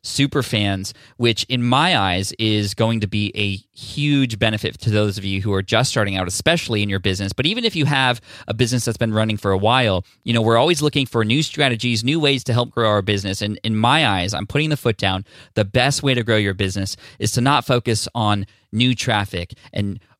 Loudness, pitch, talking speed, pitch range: -19 LUFS, 115 Hz, 230 wpm, 105-125 Hz